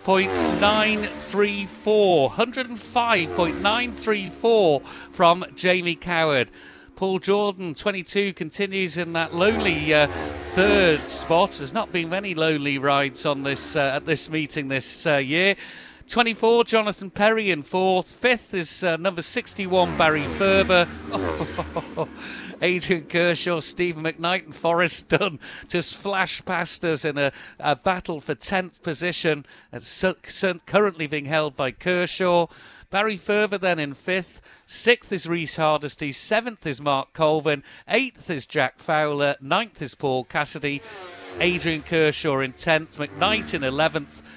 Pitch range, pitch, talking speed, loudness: 150-195 Hz, 175 Hz, 130 wpm, -23 LUFS